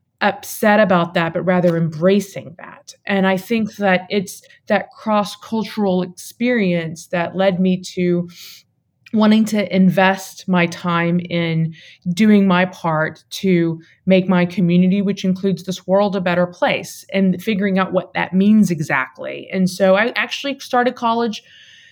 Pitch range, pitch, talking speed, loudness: 175-205 Hz, 190 Hz, 145 wpm, -17 LUFS